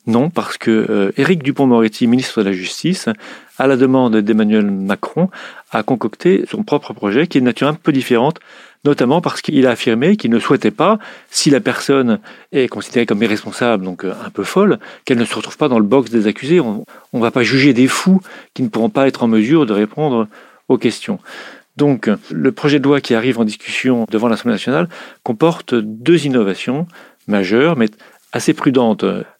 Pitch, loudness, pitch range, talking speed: 125 Hz, -15 LUFS, 110-145 Hz, 190 wpm